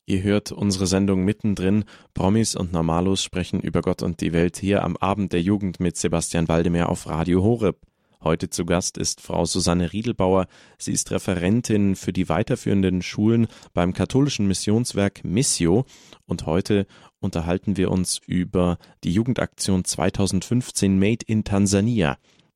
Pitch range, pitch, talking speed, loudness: 90-100 Hz, 95 Hz, 145 wpm, -22 LUFS